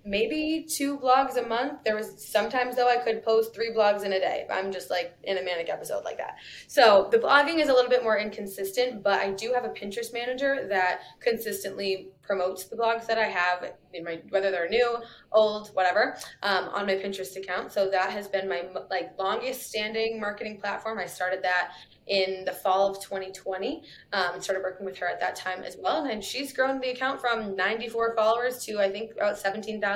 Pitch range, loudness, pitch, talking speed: 190-235 Hz, -27 LUFS, 205 Hz, 205 wpm